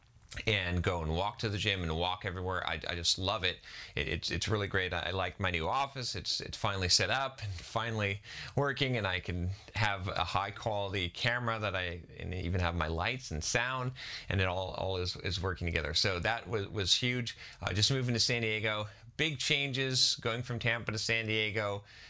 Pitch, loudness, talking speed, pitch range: 100 Hz, -33 LUFS, 210 wpm, 90-115 Hz